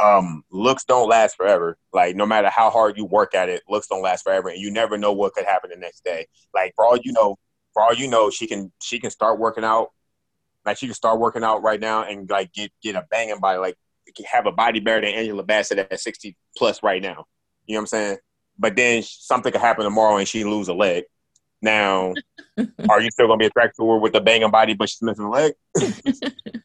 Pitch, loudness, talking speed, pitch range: 110 Hz, -20 LUFS, 240 wpm, 105-120 Hz